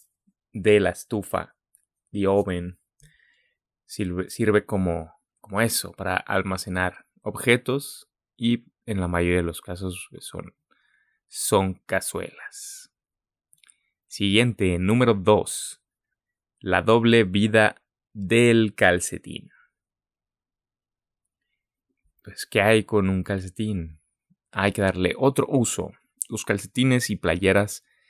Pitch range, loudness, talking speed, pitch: 95-115 Hz, -23 LUFS, 100 wpm, 100 Hz